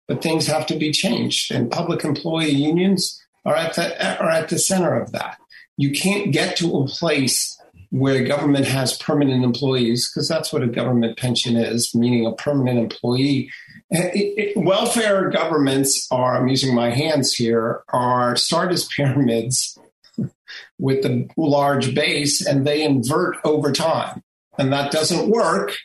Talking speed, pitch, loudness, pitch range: 160 wpm, 145 Hz, -19 LUFS, 125-160 Hz